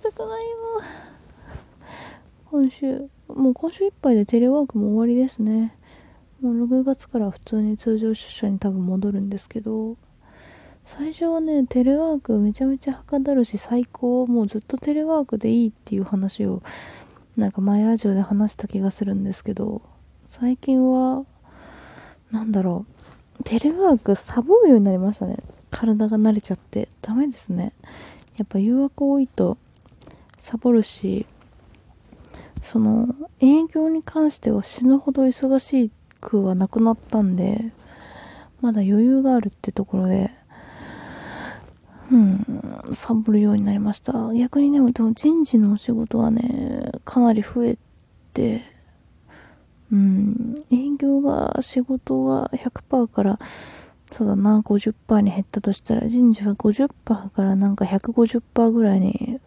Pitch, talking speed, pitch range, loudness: 230 Hz, 270 characters per minute, 210-265 Hz, -21 LUFS